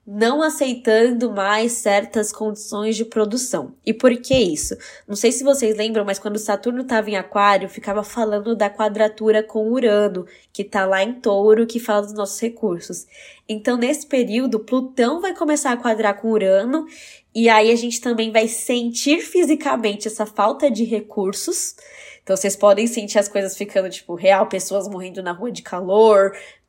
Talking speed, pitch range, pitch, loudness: 170 wpm, 205-240 Hz, 220 Hz, -19 LUFS